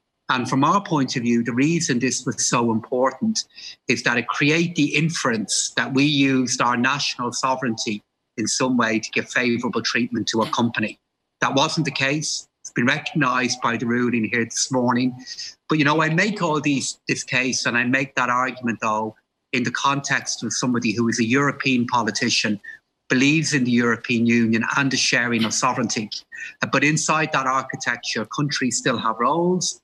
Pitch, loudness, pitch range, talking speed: 130 Hz, -21 LUFS, 120-145 Hz, 180 wpm